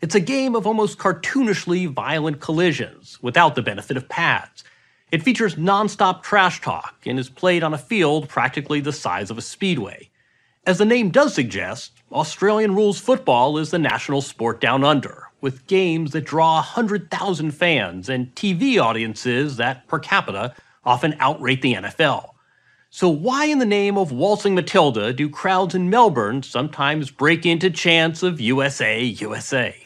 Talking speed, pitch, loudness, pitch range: 160 wpm, 160 Hz, -20 LUFS, 135-195 Hz